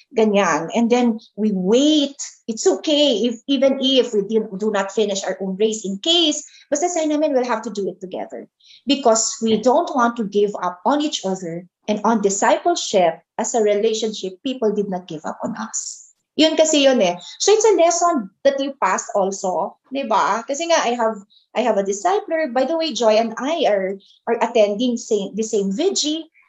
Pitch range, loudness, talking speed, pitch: 205-280 Hz, -19 LUFS, 195 wpm, 225 Hz